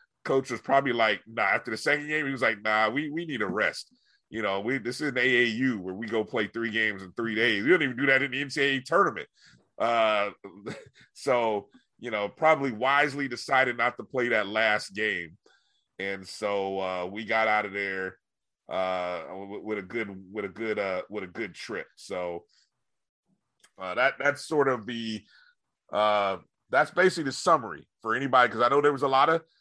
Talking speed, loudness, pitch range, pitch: 200 wpm, -27 LUFS, 105-135 Hz, 115 Hz